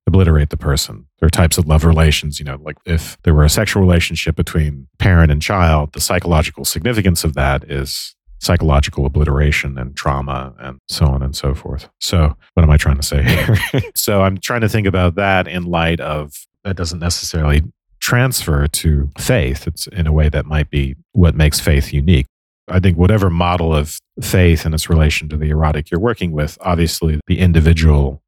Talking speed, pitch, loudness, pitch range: 195 wpm, 80 Hz, -15 LUFS, 75-90 Hz